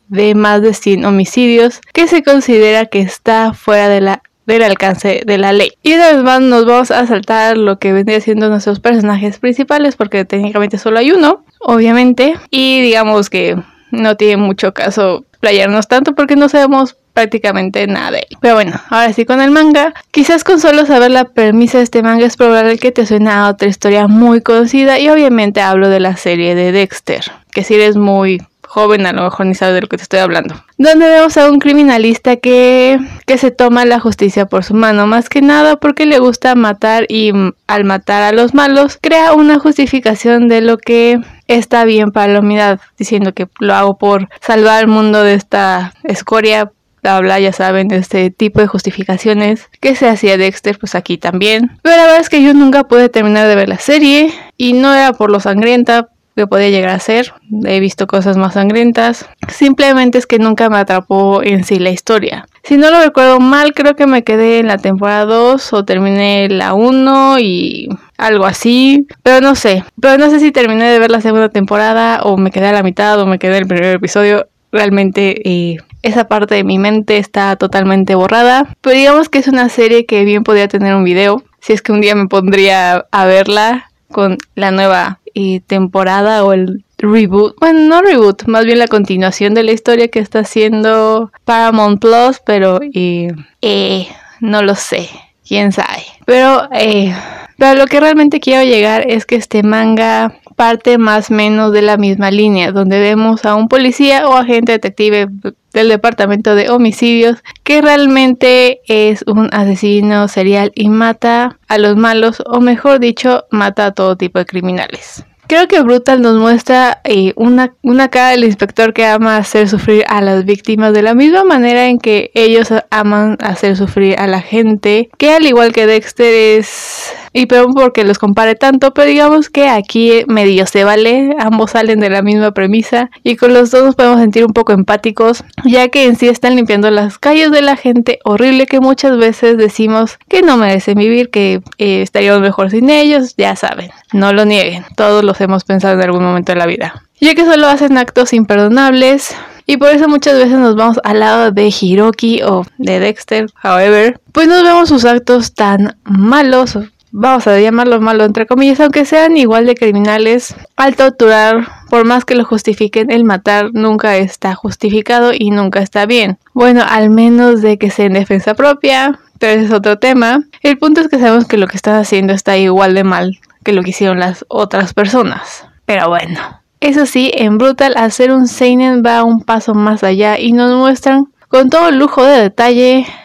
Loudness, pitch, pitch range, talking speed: -9 LUFS, 220 Hz, 205-250 Hz, 195 wpm